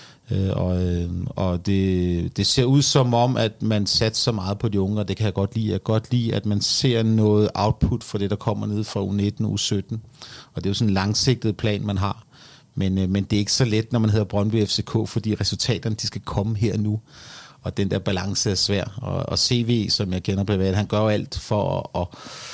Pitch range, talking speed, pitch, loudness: 100-115 Hz, 240 wpm, 105 Hz, -22 LUFS